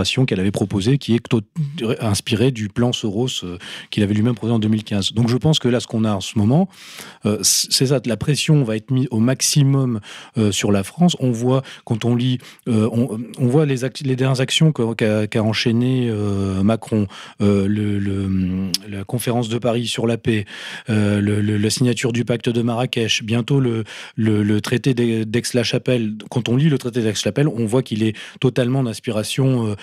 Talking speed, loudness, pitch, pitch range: 195 wpm, -19 LUFS, 115 Hz, 105-130 Hz